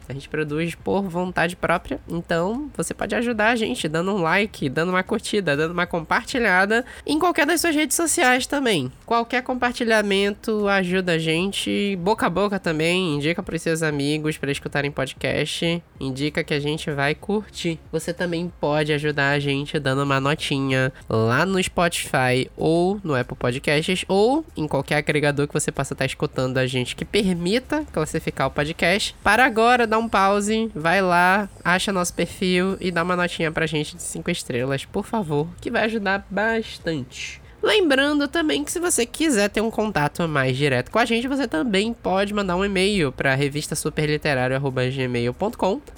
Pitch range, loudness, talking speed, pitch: 150-210 Hz, -22 LUFS, 170 wpm, 170 Hz